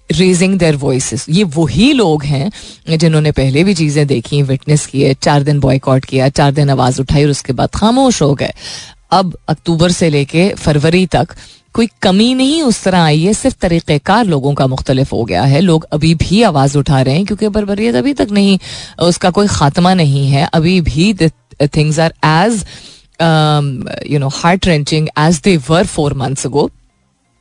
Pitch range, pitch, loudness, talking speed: 140-185 Hz, 155 Hz, -12 LUFS, 175 wpm